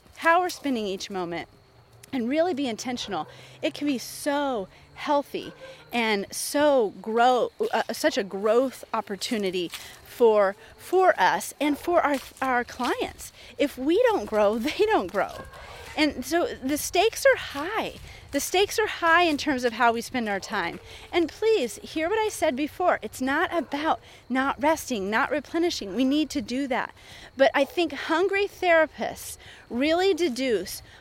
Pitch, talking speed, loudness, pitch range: 285 Hz, 155 wpm, -25 LUFS, 235-335 Hz